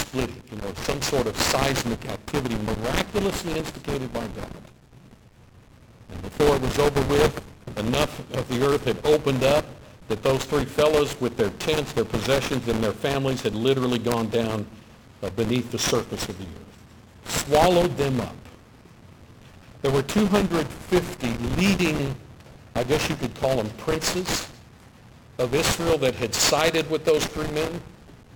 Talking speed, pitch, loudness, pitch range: 150 wpm, 130 Hz, -24 LUFS, 115-150 Hz